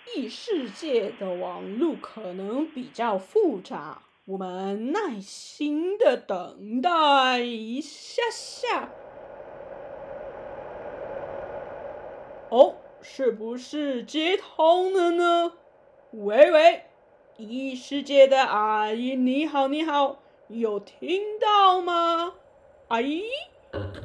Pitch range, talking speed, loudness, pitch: 245-330 Hz, 120 characters per minute, -24 LUFS, 285 Hz